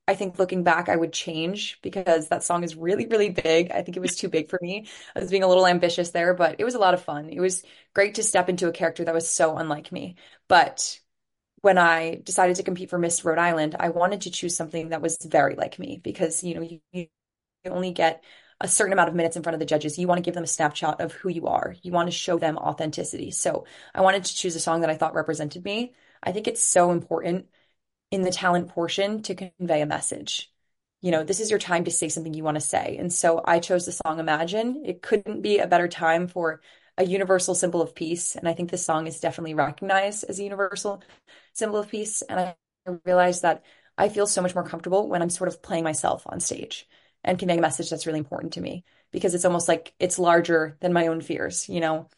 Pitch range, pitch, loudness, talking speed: 165-185 Hz, 175 Hz, -24 LUFS, 245 wpm